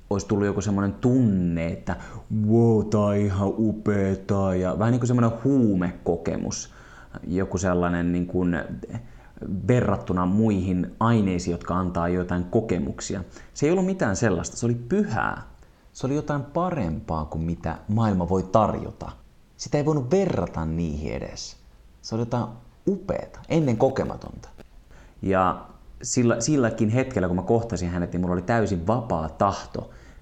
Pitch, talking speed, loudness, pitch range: 100 Hz, 140 wpm, -24 LUFS, 90-115 Hz